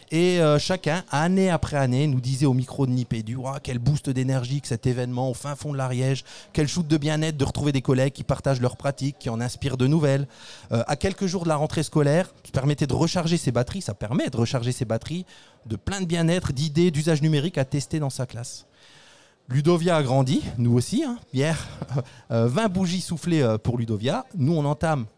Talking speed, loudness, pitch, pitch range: 210 wpm, -24 LUFS, 140 Hz, 130-160 Hz